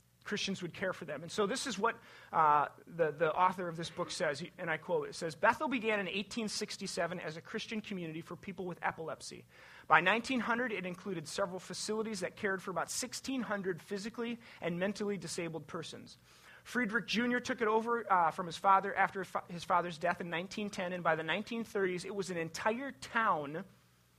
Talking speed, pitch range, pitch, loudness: 190 wpm, 170-220 Hz, 195 Hz, -35 LUFS